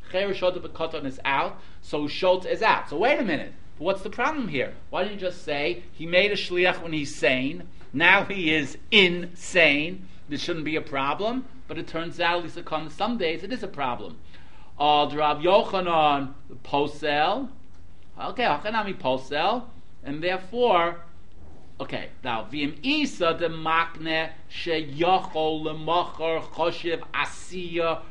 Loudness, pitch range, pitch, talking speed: -25 LUFS, 145-180 Hz, 160 Hz, 150 wpm